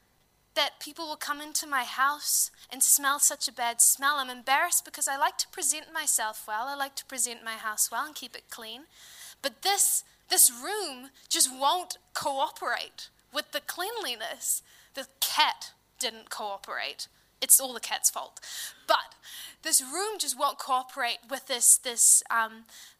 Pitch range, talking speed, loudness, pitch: 245-310 Hz, 160 wpm, -26 LUFS, 275 Hz